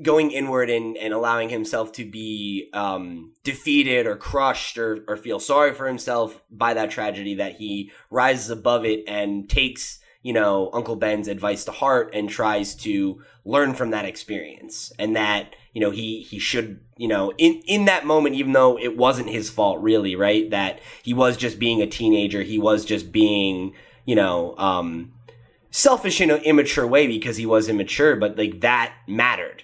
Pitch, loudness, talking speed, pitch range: 115 Hz, -21 LUFS, 180 wpm, 105-130 Hz